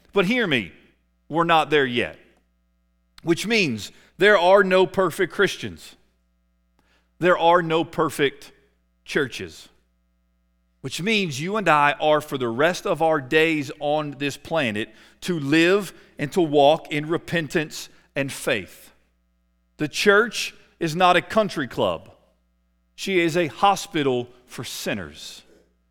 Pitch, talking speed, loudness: 150 Hz, 130 wpm, -21 LUFS